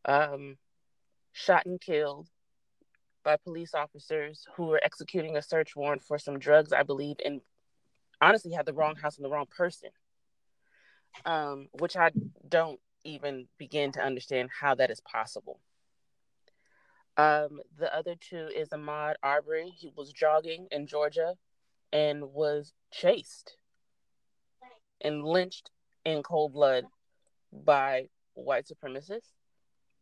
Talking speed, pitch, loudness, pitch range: 125 wpm, 150 Hz, -30 LUFS, 145-165 Hz